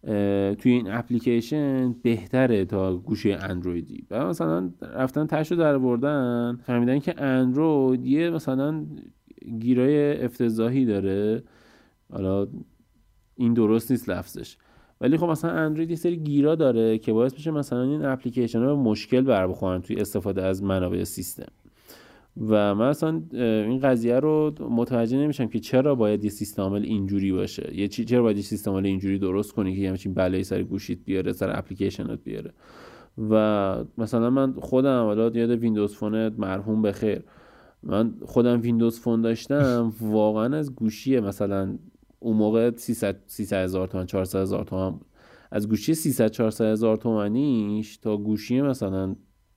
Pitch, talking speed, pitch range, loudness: 115 Hz, 145 wpm, 100-130 Hz, -24 LUFS